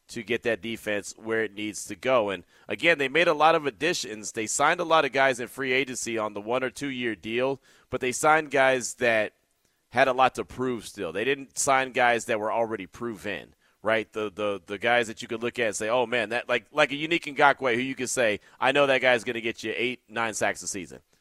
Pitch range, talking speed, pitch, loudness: 110-135 Hz, 250 wpm, 120 Hz, -26 LUFS